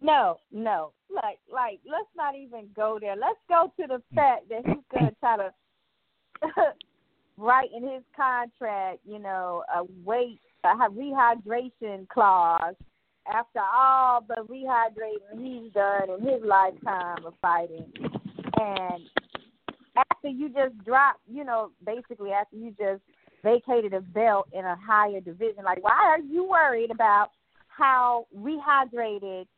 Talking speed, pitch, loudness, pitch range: 140 wpm, 230 Hz, -26 LUFS, 200-270 Hz